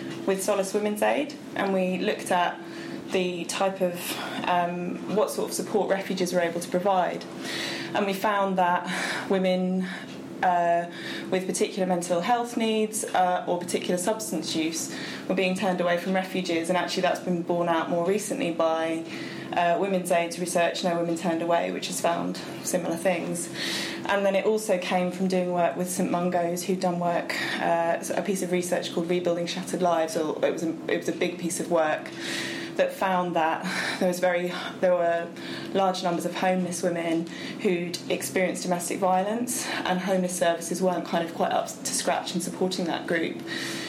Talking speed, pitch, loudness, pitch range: 180 wpm, 180 Hz, -26 LUFS, 175-190 Hz